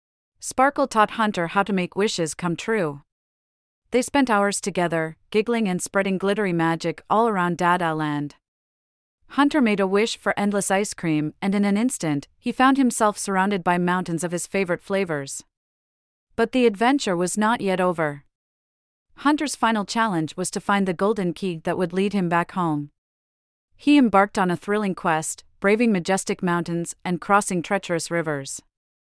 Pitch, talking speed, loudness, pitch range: 185 Hz, 165 wpm, -22 LUFS, 160-210 Hz